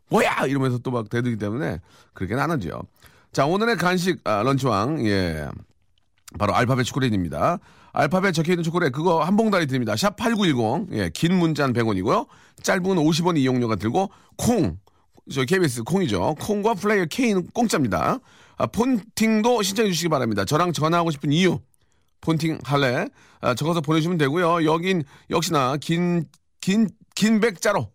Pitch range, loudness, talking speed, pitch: 125-190 Hz, -22 LUFS, 335 characters per minute, 160 Hz